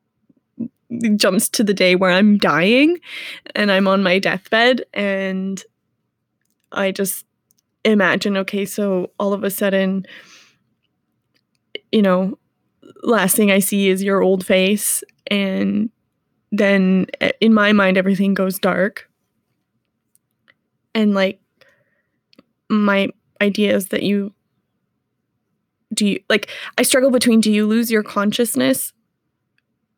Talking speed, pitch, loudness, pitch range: 120 wpm, 200 Hz, -17 LUFS, 195-225 Hz